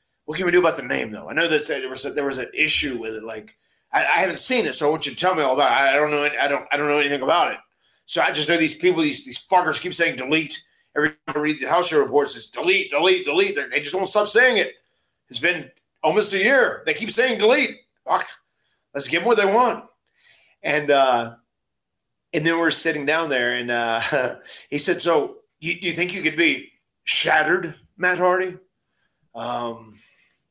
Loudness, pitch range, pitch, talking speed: -20 LUFS, 140-210 Hz, 165 Hz, 230 wpm